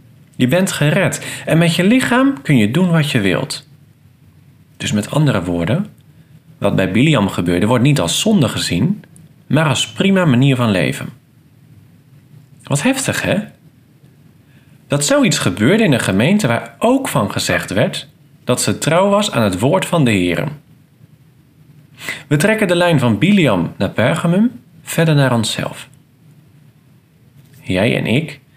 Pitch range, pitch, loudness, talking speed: 130-160 Hz, 145 Hz, -15 LUFS, 145 wpm